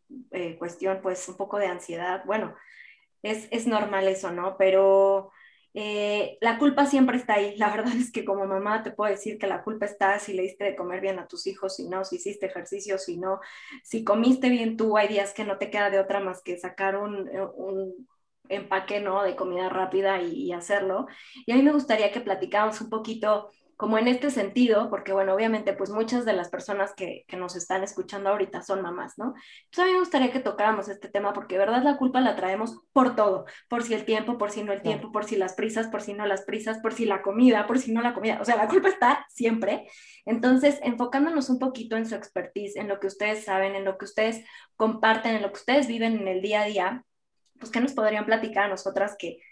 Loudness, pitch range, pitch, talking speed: -26 LUFS, 195-225 Hz, 205 Hz, 230 wpm